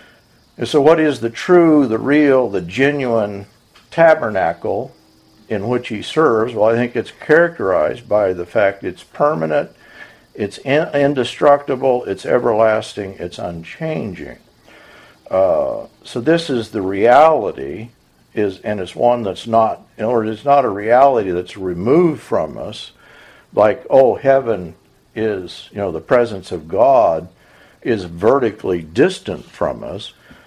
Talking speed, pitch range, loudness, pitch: 140 wpm, 100-140 Hz, -16 LUFS, 120 Hz